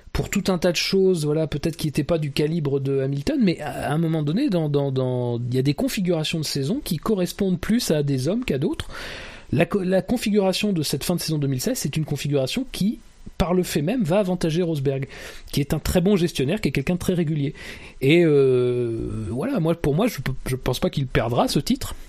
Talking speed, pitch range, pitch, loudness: 230 wpm, 140-185 Hz, 160 Hz, -23 LUFS